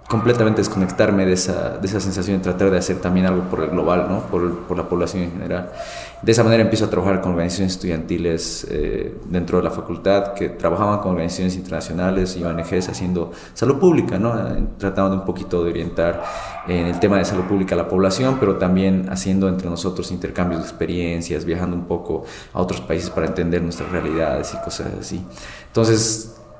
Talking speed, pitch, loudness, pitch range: 190 wpm, 90 Hz, -20 LUFS, 85-95 Hz